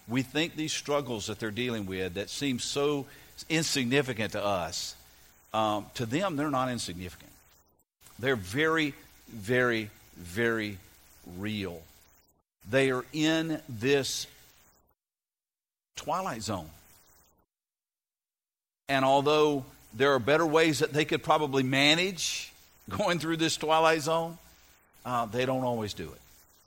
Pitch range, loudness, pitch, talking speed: 95-145 Hz, -29 LUFS, 125 Hz, 120 wpm